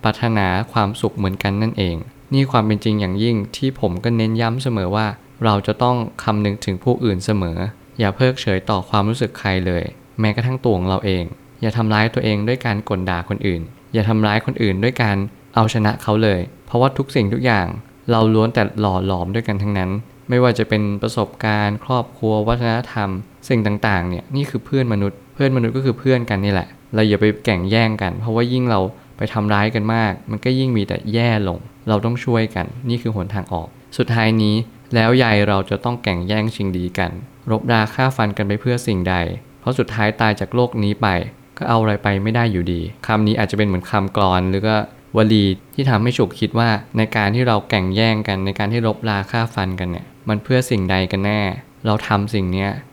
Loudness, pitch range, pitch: -19 LUFS, 100-120 Hz, 110 Hz